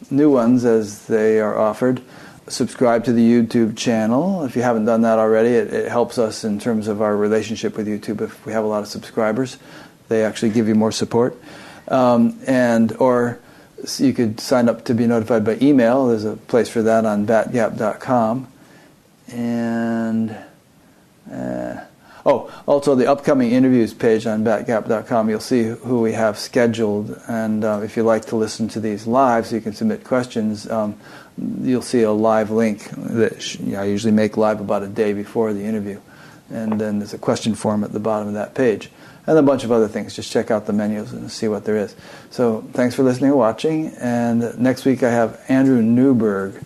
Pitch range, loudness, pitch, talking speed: 110-120 Hz, -19 LUFS, 115 Hz, 195 wpm